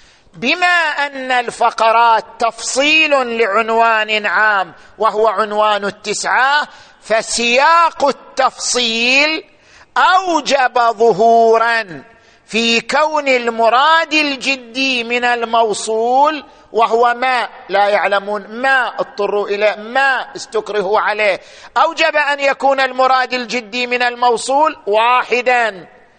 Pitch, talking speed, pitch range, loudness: 240 Hz, 85 wpm, 225-270 Hz, -14 LUFS